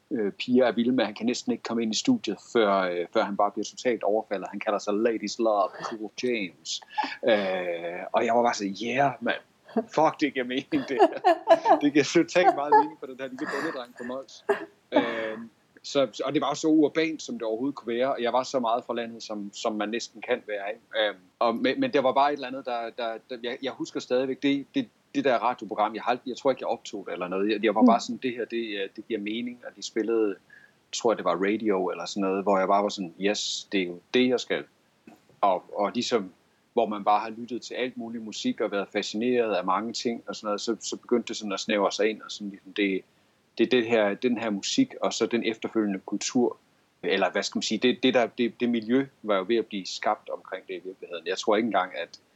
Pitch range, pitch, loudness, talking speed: 105-135 Hz, 115 Hz, -27 LUFS, 245 wpm